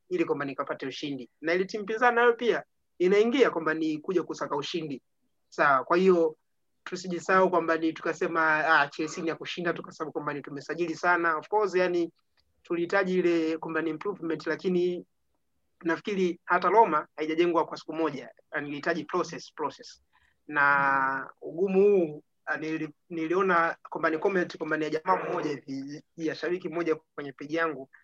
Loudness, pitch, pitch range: -28 LUFS, 165 Hz, 155-180 Hz